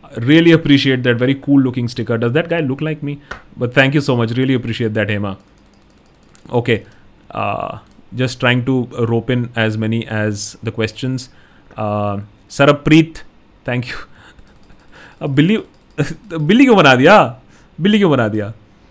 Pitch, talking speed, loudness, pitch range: 125 Hz, 140 wpm, -15 LUFS, 110-145 Hz